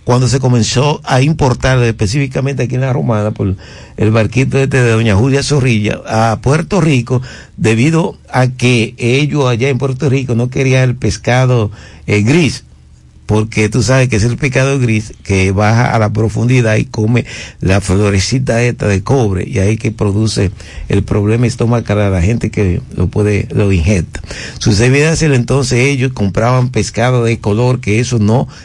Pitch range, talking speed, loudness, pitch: 105-130 Hz, 170 wpm, -12 LUFS, 115 Hz